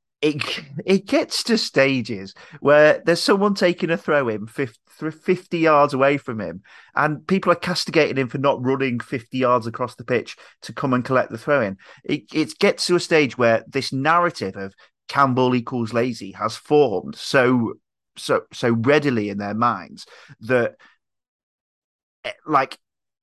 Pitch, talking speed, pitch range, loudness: 140 Hz, 160 wpm, 120-160 Hz, -20 LUFS